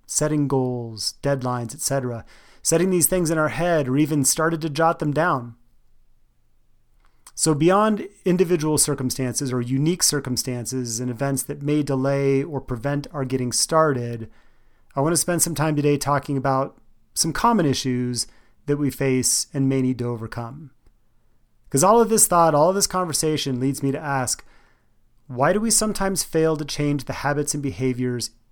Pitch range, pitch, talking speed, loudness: 125-160 Hz, 140 Hz, 165 wpm, -21 LUFS